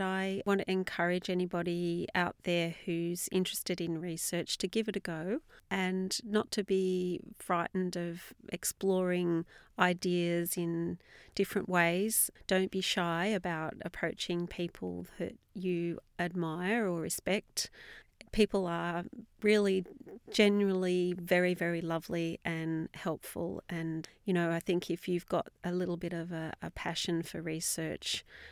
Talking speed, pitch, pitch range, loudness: 135 wpm, 175 Hz, 170-190 Hz, -34 LUFS